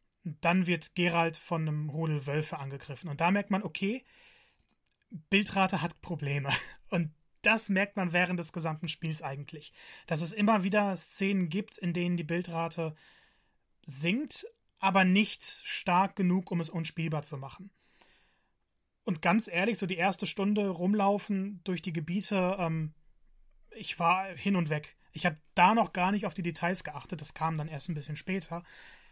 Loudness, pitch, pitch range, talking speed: -31 LUFS, 175 Hz, 160-195 Hz, 160 wpm